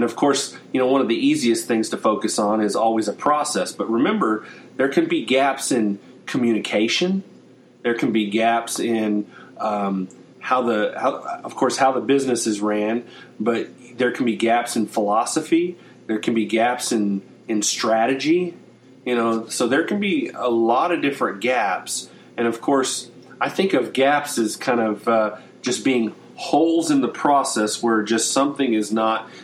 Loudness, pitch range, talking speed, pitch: -21 LUFS, 110-135 Hz, 180 wpm, 115 Hz